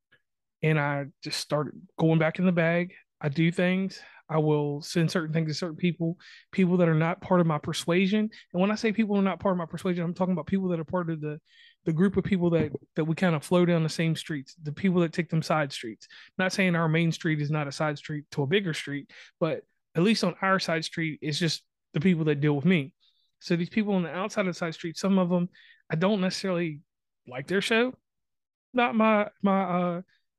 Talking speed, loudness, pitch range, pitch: 240 wpm, -27 LUFS, 160-190 Hz, 175 Hz